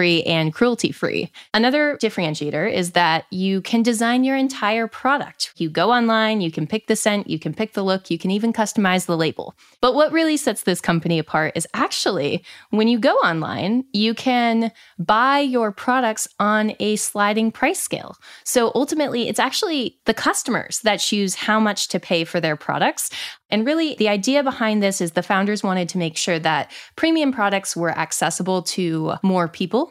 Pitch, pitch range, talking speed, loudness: 210 Hz, 175-240 Hz, 185 wpm, -20 LUFS